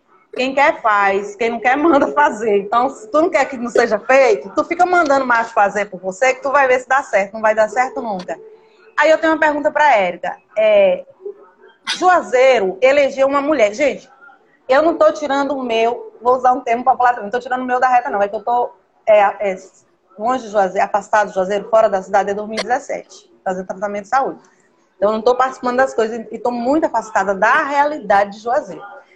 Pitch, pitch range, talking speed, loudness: 250 Hz, 215-285 Hz, 215 wpm, -16 LUFS